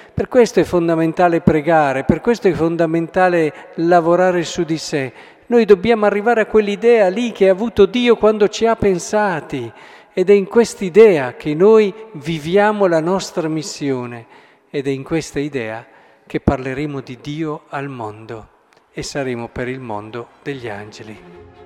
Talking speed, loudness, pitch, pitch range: 150 wpm, -16 LUFS, 165 Hz, 135-205 Hz